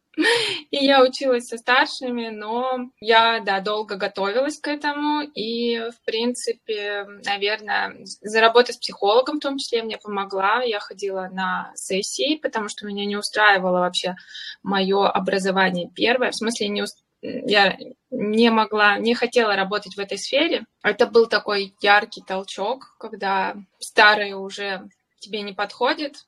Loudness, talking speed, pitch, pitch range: -21 LUFS, 130 wpm, 215 Hz, 200-245 Hz